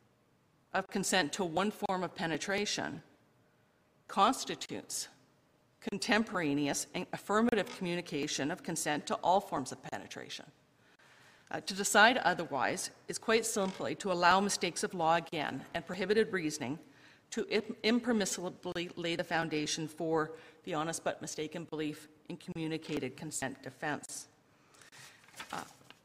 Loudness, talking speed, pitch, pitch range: -34 LUFS, 120 wpm, 175 Hz, 155-200 Hz